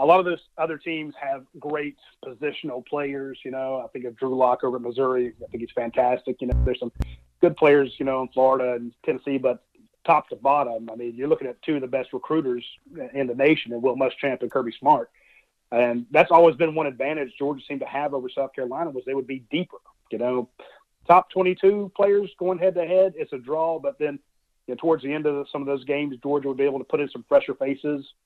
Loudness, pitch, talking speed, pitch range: -24 LUFS, 140 Hz, 235 wpm, 125-160 Hz